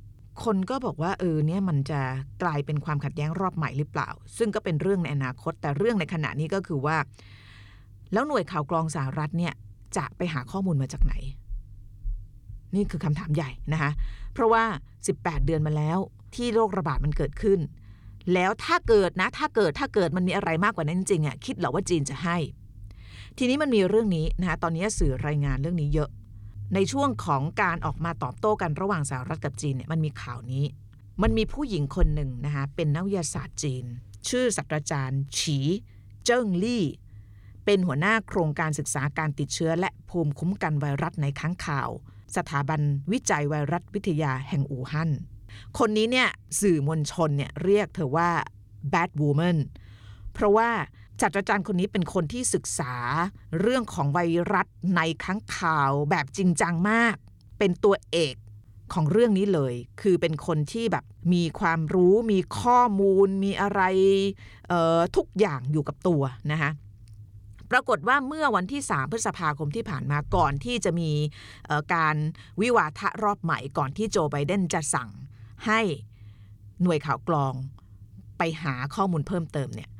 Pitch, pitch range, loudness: 155 Hz, 135-190 Hz, -26 LUFS